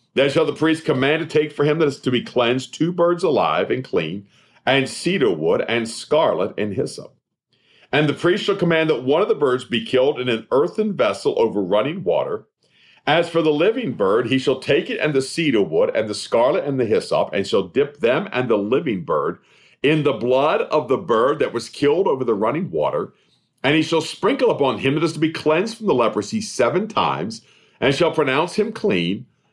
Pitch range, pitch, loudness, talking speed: 135-205 Hz, 160 Hz, -20 LUFS, 215 wpm